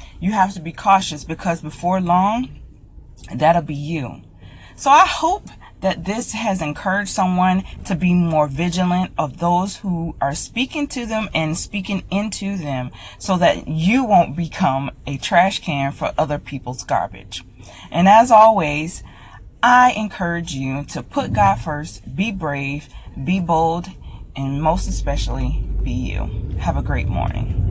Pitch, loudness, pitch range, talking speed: 165 Hz, -19 LUFS, 140-190 Hz, 150 wpm